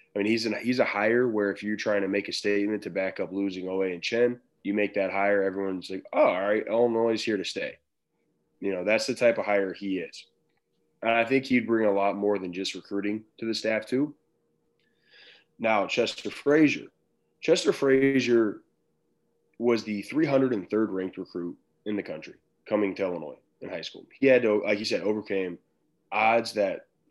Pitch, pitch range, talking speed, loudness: 105 Hz, 95-115 Hz, 195 wpm, -27 LUFS